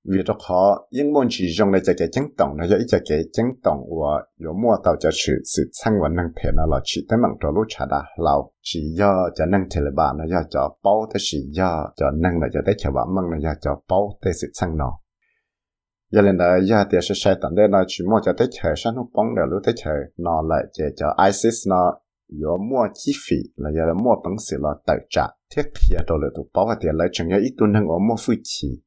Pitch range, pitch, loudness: 80-100 Hz, 90 Hz, -21 LUFS